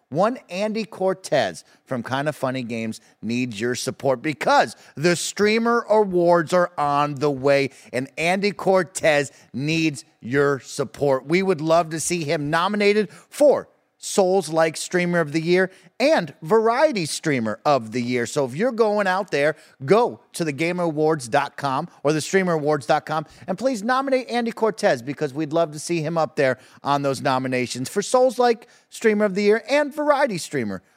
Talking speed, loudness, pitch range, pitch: 155 wpm, -22 LUFS, 140-205 Hz, 165 Hz